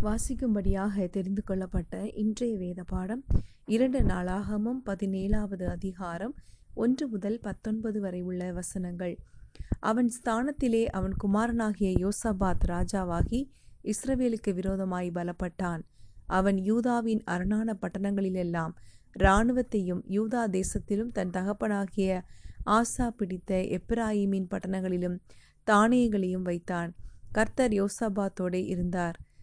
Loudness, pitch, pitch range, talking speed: -30 LUFS, 200 Hz, 185-220 Hz, 90 wpm